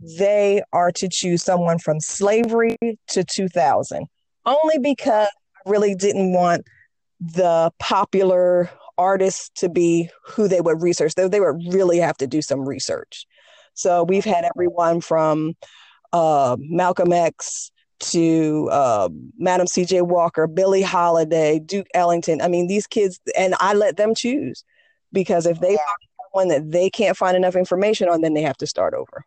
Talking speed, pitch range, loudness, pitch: 160 wpm, 170-205 Hz, -19 LUFS, 180 Hz